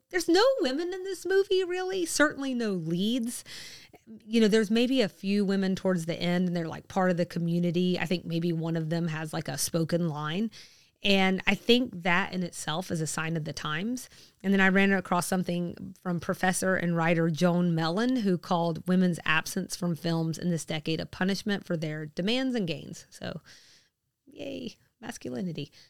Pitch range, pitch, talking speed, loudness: 170-210 Hz, 180 Hz, 190 wpm, -28 LUFS